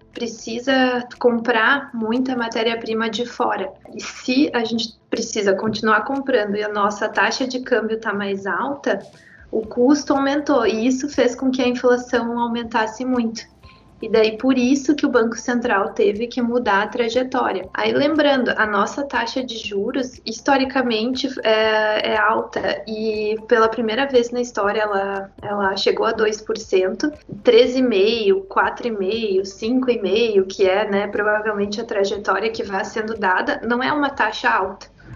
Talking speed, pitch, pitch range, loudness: 150 wpm, 230 Hz, 215-255 Hz, -20 LUFS